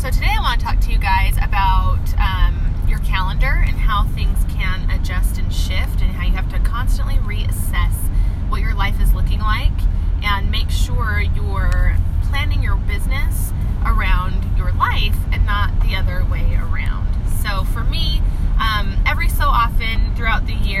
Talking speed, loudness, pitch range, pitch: 170 wpm, -20 LUFS, 85-95 Hz, 90 Hz